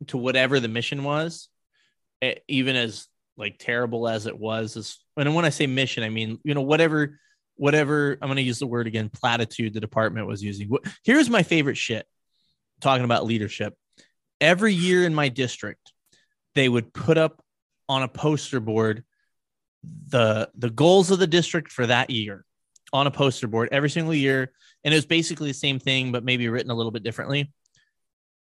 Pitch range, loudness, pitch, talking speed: 115-150 Hz, -23 LUFS, 130 Hz, 180 wpm